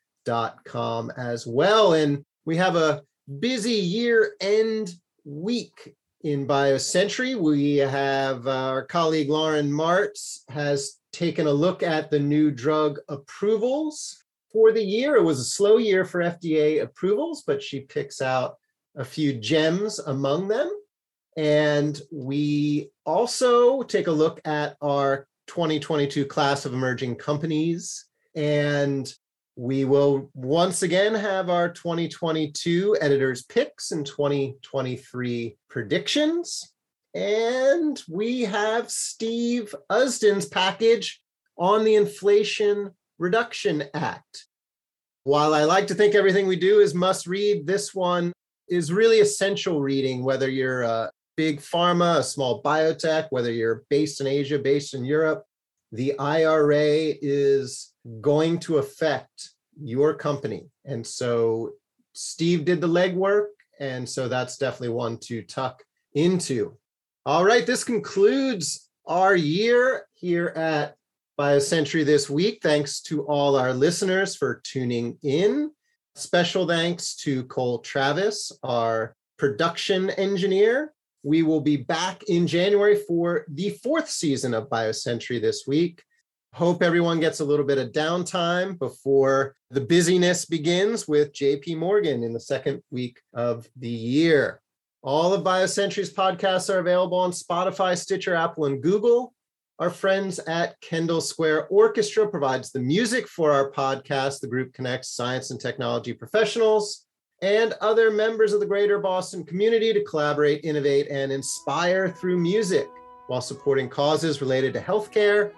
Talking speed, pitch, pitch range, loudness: 135 wpm, 160 Hz, 140-200 Hz, -23 LUFS